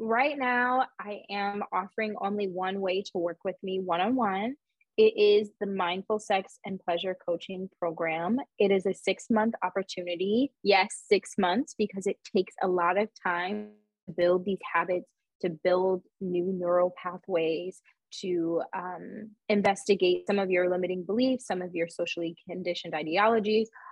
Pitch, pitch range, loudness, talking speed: 190 Hz, 180-215 Hz, -29 LUFS, 160 wpm